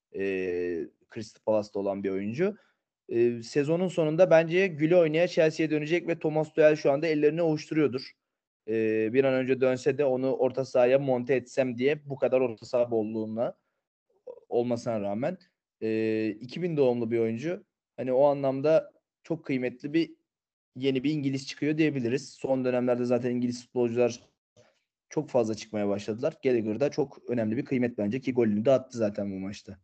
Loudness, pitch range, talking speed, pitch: -28 LUFS, 115-155 Hz, 155 wpm, 130 Hz